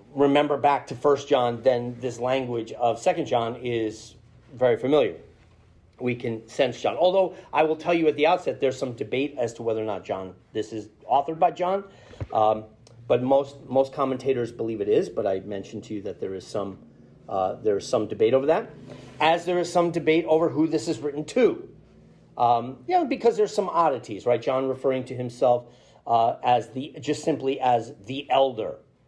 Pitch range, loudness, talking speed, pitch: 115-155 Hz, -25 LUFS, 195 wpm, 130 Hz